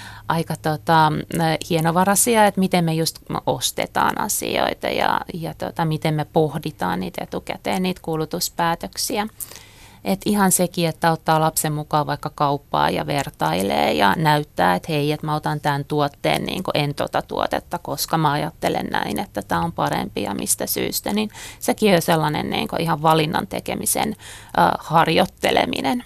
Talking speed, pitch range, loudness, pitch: 150 wpm, 145-170 Hz, -21 LUFS, 155 Hz